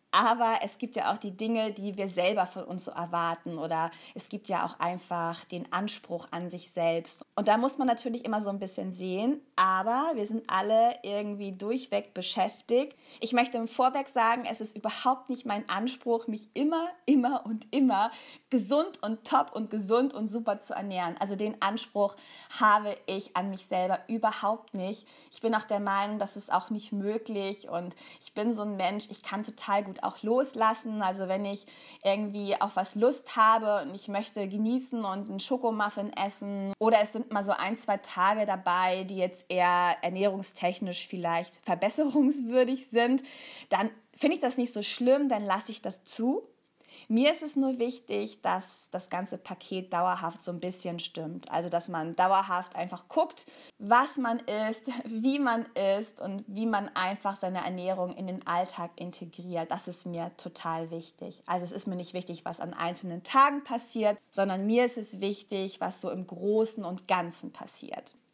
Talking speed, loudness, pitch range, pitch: 180 wpm, -30 LUFS, 185-235 Hz, 205 Hz